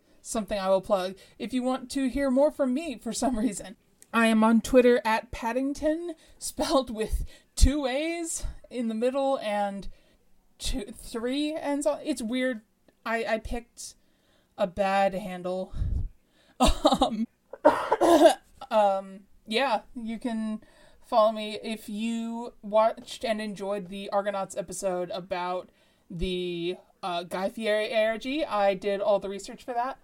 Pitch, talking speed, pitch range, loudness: 225 Hz, 140 wpm, 200-260 Hz, -28 LUFS